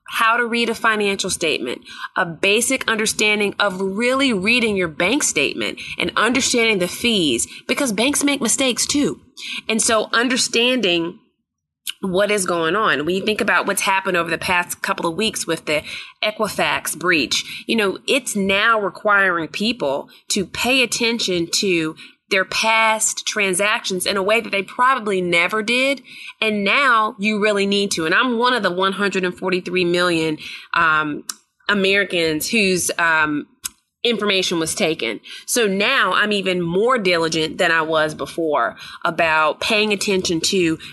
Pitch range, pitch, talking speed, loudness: 180-230 Hz, 205 Hz, 150 wpm, -18 LUFS